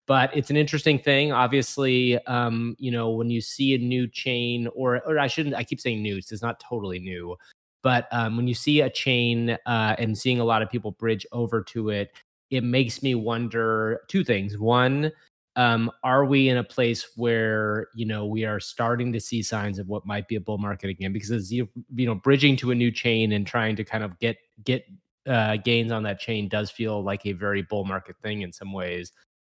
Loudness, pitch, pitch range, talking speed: -25 LUFS, 115 Hz, 105-125 Hz, 220 wpm